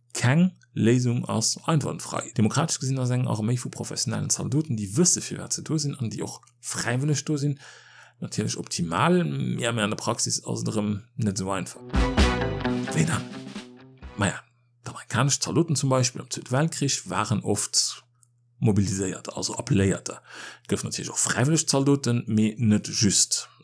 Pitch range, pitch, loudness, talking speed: 110-140 Hz, 125 Hz, -25 LUFS, 145 wpm